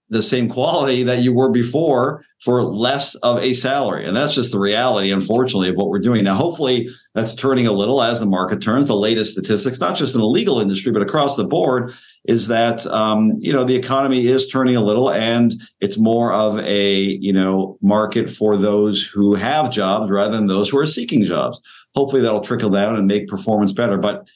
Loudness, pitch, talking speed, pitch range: -17 LUFS, 115 Hz, 210 wpm, 100-130 Hz